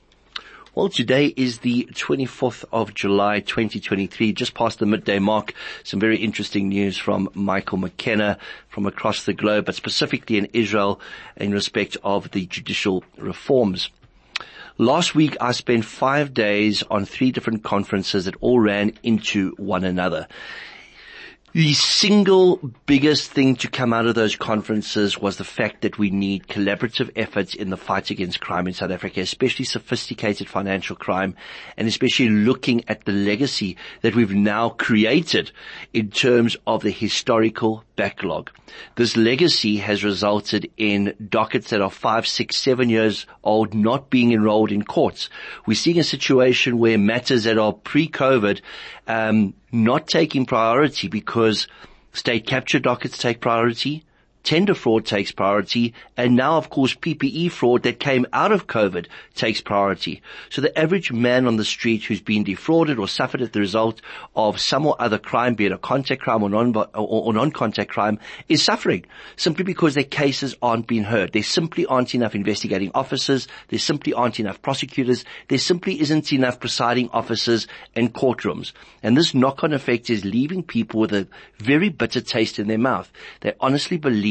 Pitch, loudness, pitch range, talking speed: 115 Hz, -20 LUFS, 105-130 Hz, 160 wpm